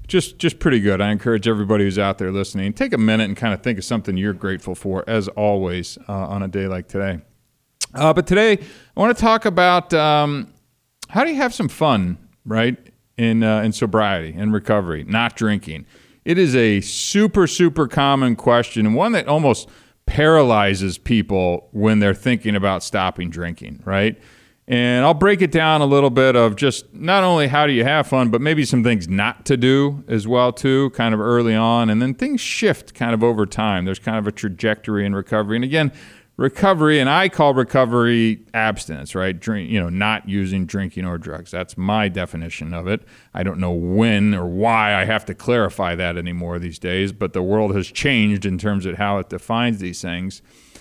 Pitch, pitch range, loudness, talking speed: 110 Hz, 100-130 Hz, -18 LUFS, 200 wpm